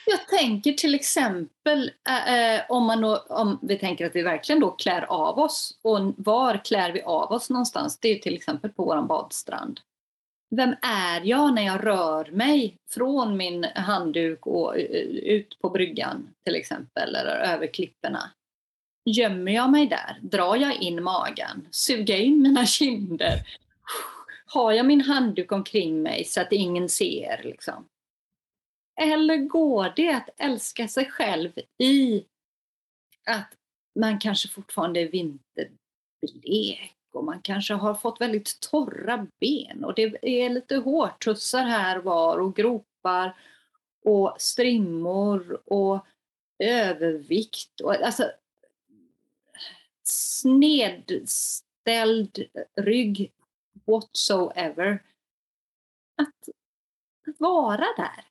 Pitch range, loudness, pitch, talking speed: 200-280 Hz, -24 LUFS, 230 Hz, 120 wpm